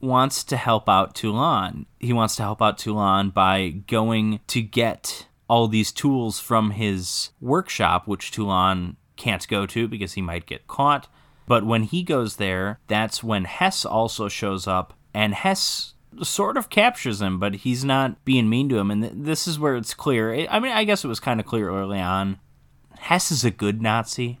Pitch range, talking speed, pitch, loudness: 100-125 Hz, 190 wpm, 110 Hz, -22 LUFS